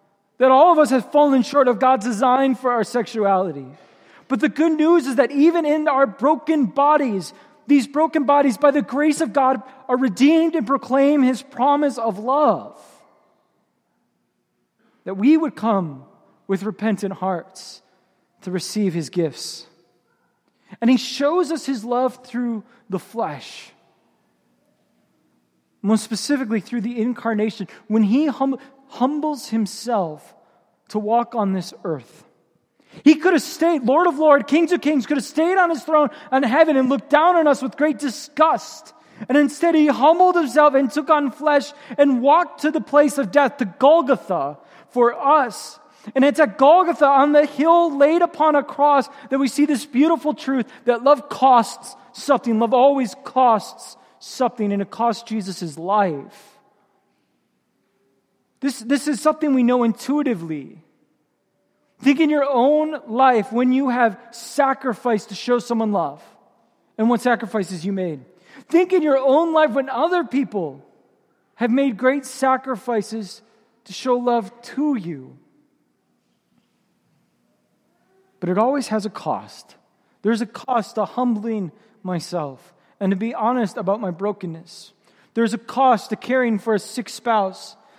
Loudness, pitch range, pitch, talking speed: -19 LUFS, 220-290 Hz, 255 Hz, 150 wpm